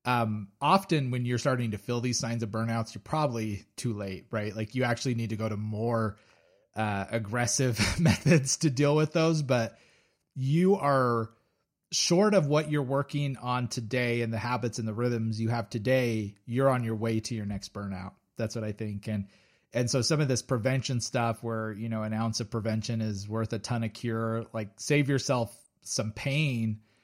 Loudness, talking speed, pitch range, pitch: -29 LUFS, 195 wpm, 110-130 Hz, 115 Hz